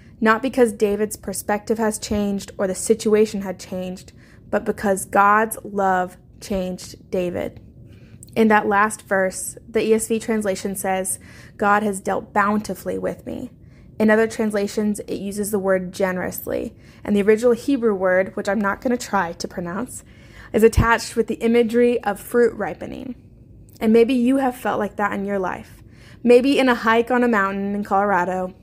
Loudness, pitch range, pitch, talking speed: -20 LUFS, 190-225 Hz, 205 Hz, 165 wpm